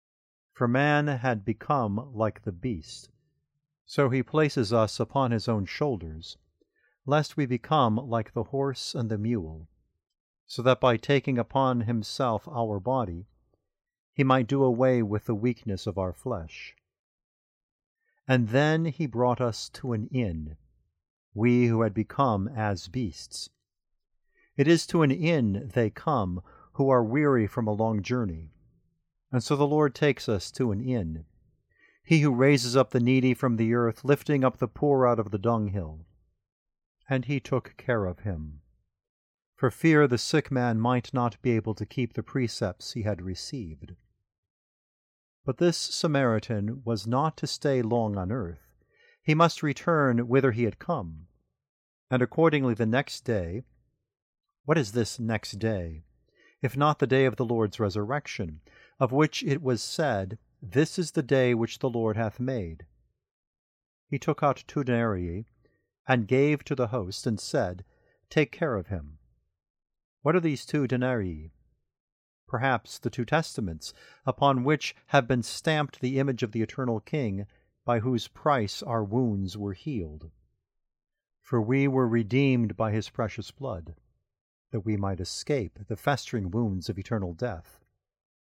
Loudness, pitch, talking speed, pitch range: -27 LUFS, 120 Hz, 155 wpm, 105-135 Hz